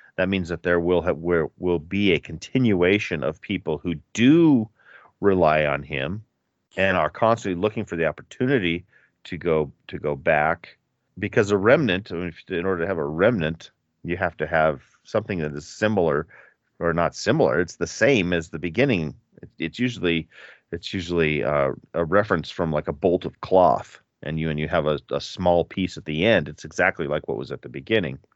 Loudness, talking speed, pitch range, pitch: -23 LUFS, 185 wpm, 80-95 Hz, 85 Hz